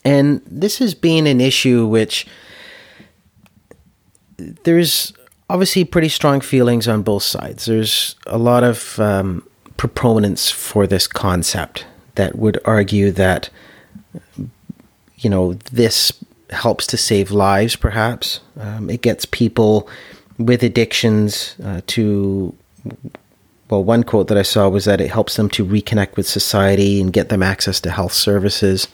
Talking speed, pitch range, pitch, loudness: 135 wpm, 100-120 Hz, 105 Hz, -16 LUFS